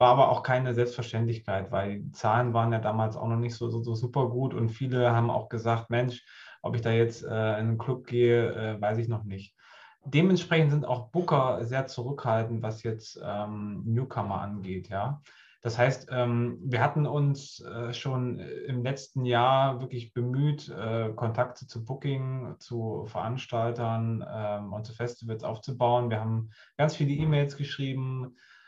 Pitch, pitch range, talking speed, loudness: 120 Hz, 115-130 Hz, 170 wpm, -29 LUFS